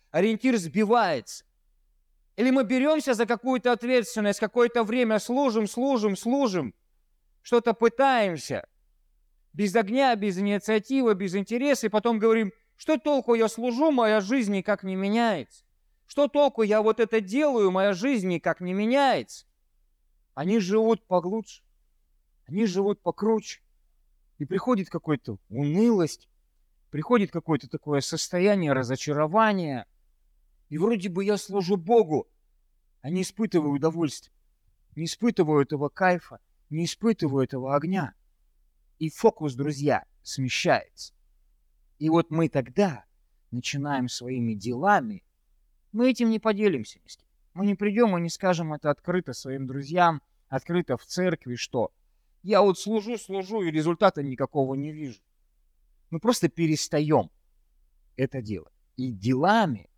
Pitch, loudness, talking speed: 175 Hz, -25 LUFS, 120 wpm